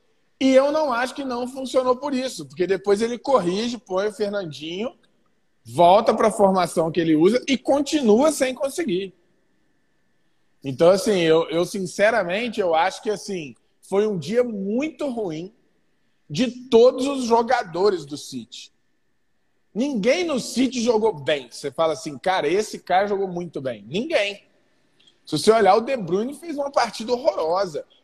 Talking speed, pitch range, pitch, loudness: 155 wpm, 180-255 Hz, 210 Hz, -21 LUFS